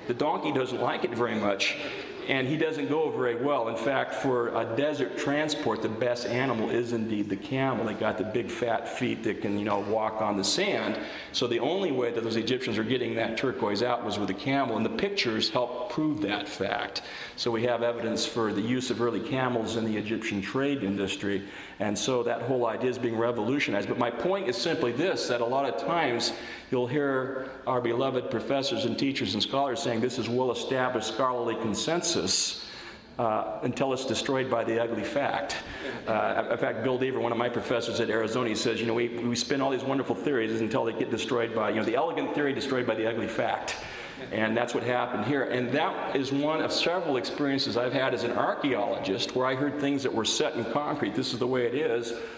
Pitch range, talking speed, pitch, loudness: 110-130 Hz, 220 wpm, 120 Hz, -28 LUFS